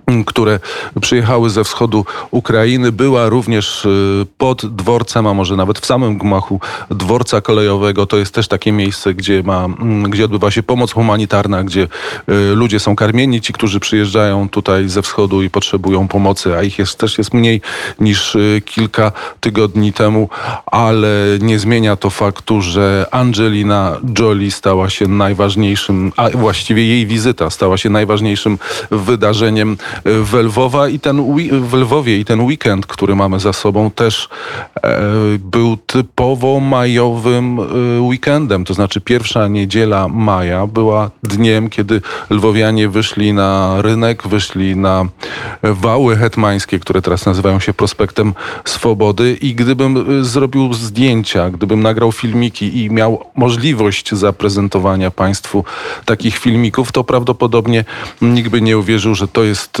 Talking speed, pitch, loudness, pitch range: 135 wpm, 110 Hz, -13 LUFS, 100-115 Hz